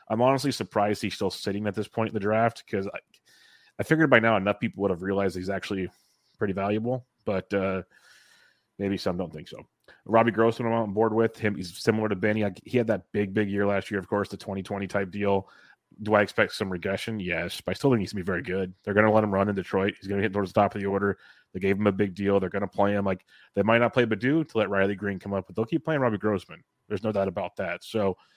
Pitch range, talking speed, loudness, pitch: 100-110 Hz, 270 wpm, -27 LUFS, 100 Hz